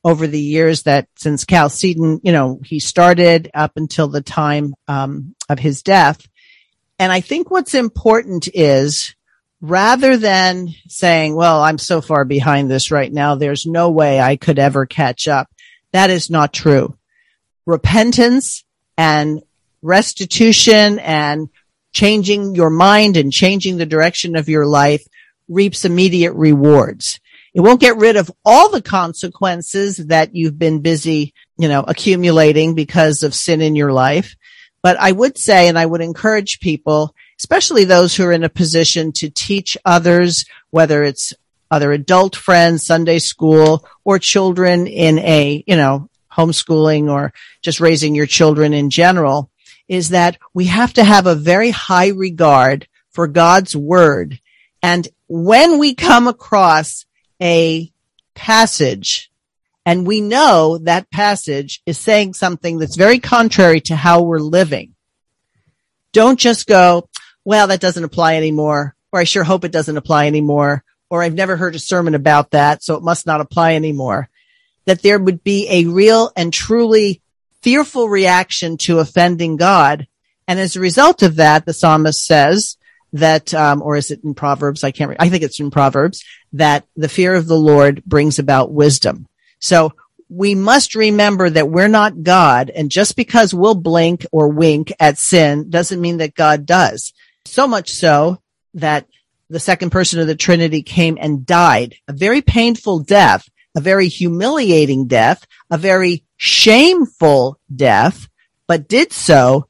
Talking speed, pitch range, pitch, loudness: 155 wpm, 150-190 Hz, 170 Hz, -12 LUFS